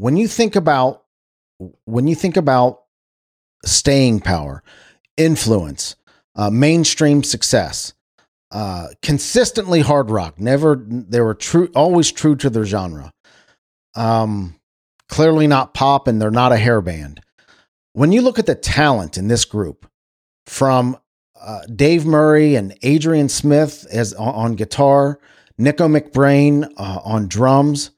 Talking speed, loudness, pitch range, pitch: 135 wpm, -16 LUFS, 105-150 Hz, 130 Hz